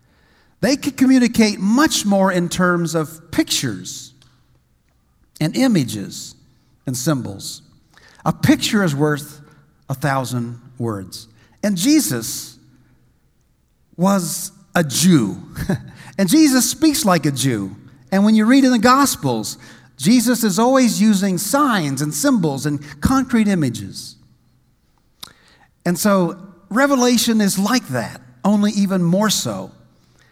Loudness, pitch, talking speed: -17 LUFS, 185 Hz, 115 wpm